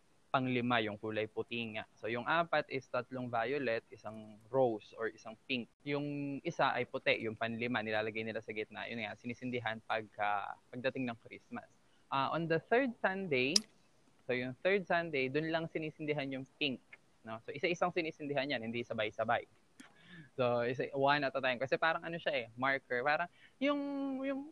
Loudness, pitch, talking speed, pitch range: -36 LUFS, 130 Hz, 170 wpm, 115-155 Hz